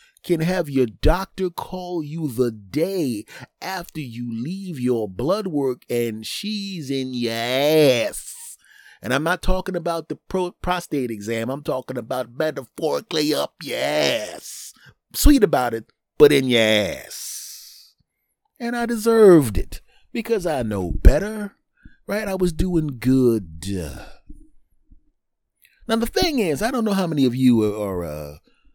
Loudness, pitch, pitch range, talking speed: -22 LUFS, 150 Hz, 120-190 Hz, 145 wpm